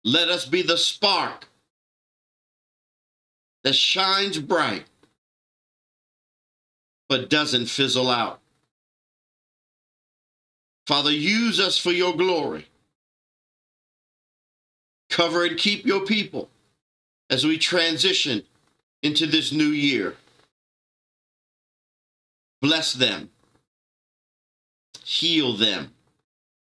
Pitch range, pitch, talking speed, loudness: 135-180 Hz, 160 Hz, 75 wpm, -21 LUFS